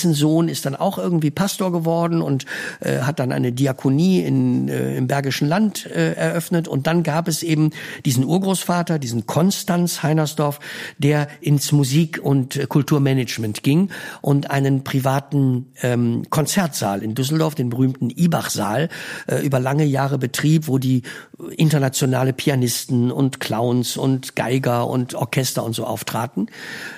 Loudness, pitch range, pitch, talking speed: -20 LUFS, 130-160 Hz, 140 Hz, 145 wpm